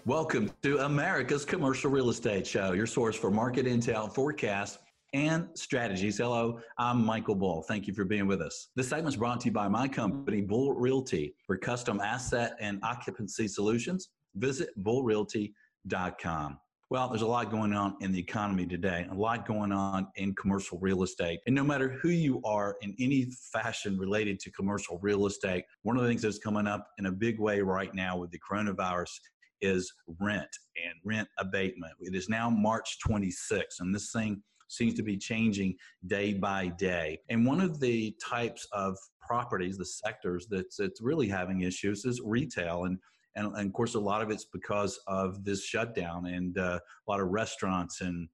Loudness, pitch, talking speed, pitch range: -32 LUFS, 105 Hz, 185 wpm, 95-115 Hz